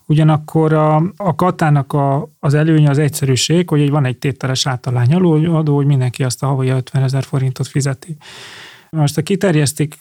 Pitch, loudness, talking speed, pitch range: 150 Hz, -15 LUFS, 170 wpm, 135-155 Hz